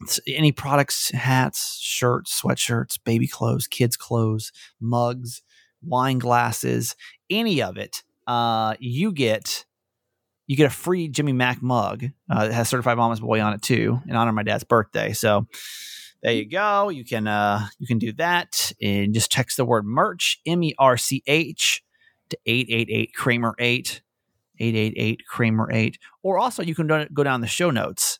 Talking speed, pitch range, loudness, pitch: 170 wpm, 115-145 Hz, -22 LUFS, 120 Hz